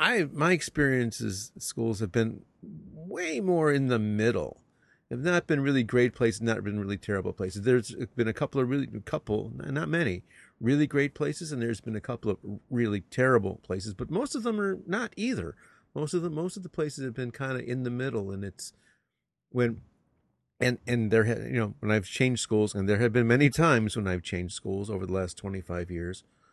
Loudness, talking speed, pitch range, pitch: -29 LUFS, 210 wpm, 105-140 Hz, 120 Hz